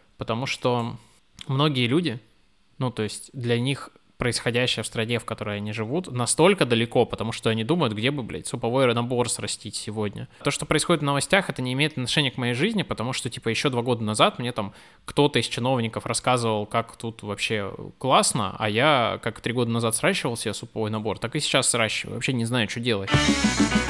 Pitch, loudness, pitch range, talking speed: 120 Hz, -24 LUFS, 115-135 Hz, 195 wpm